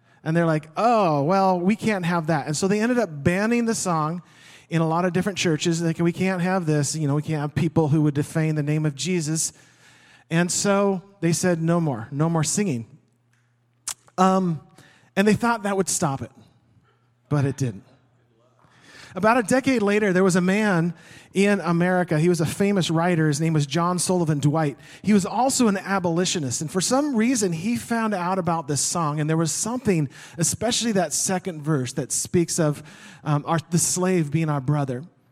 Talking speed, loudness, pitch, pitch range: 195 wpm, -22 LUFS, 165 Hz, 150-190 Hz